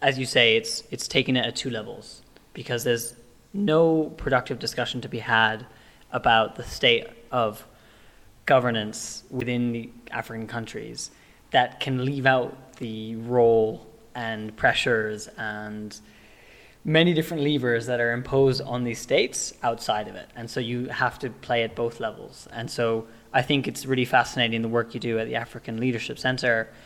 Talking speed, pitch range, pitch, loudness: 165 wpm, 115-130 Hz, 120 Hz, -25 LUFS